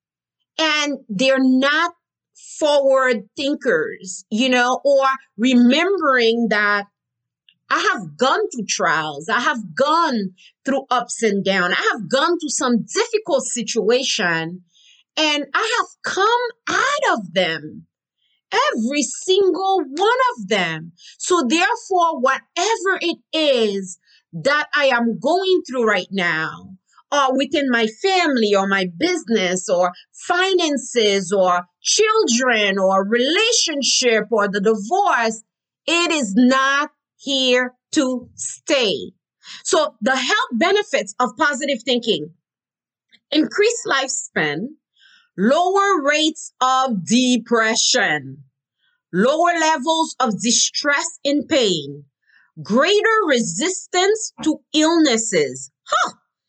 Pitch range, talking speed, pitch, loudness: 215-325 Hz, 105 wpm, 265 Hz, -18 LUFS